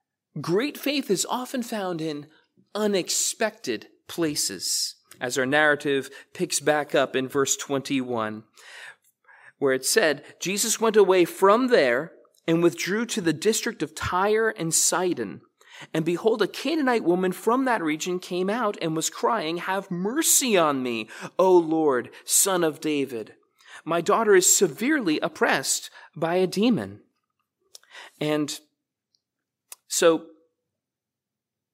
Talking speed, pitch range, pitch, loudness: 125 wpm, 150-220 Hz, 175 Hz, -23 LUFS